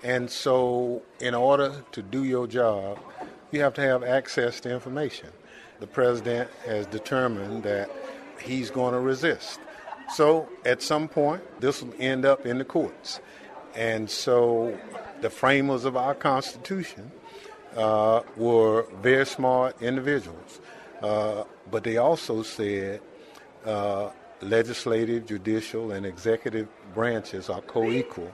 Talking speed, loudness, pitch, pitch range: 130 wpm, -26 LUFS, 120 Hz, 110-130 Hz